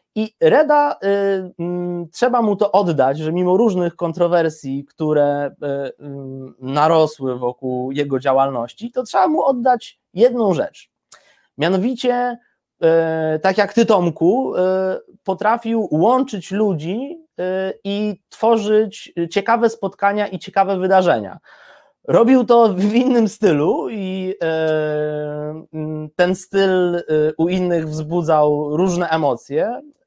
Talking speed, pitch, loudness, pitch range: 115 wpm, 185 Hz, -18 LUFS, 155-215 Hz